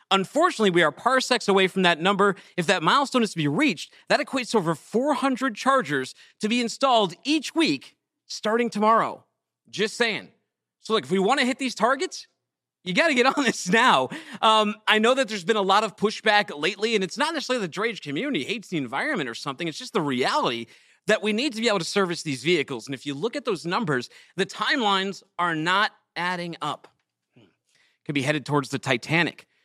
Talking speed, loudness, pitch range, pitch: 205 wpm, -23 LUFS, 175-240 Hz, 210 Hz